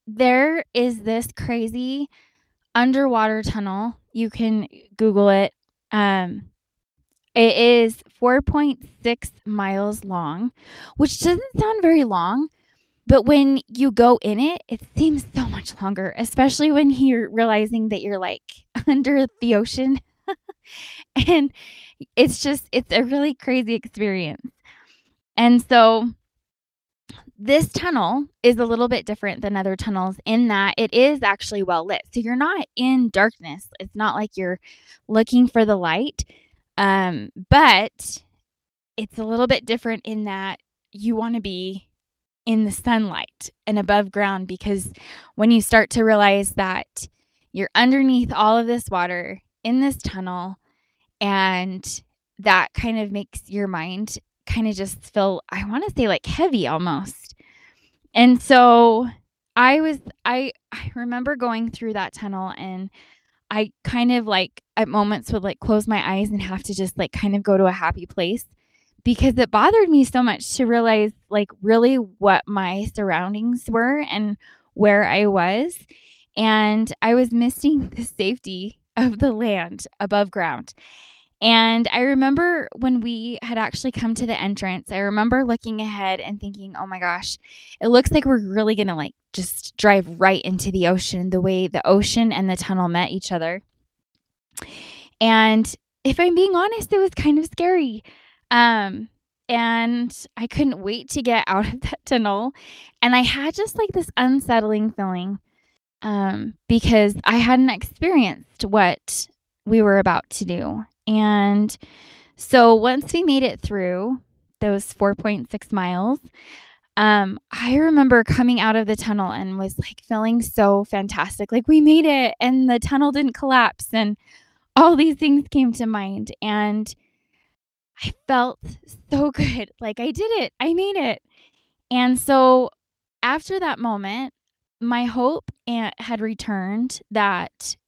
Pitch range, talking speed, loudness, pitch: 200-255 Hz, 150 wpm, -20 LUFS, 225 Hz